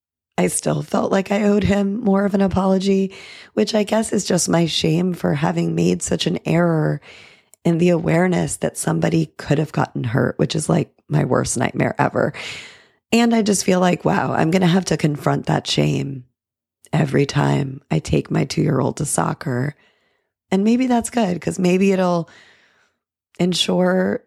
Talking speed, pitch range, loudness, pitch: 180 wpm, 145-195 Hz, -19 LUFS, 175 Hz